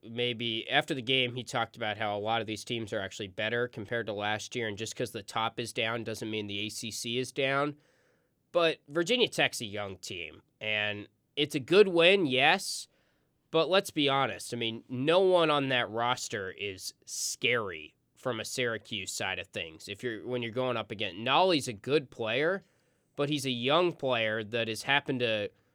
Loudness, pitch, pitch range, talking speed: -30 LUFS, 120 Hz, 110-135 Hz, 195 wpm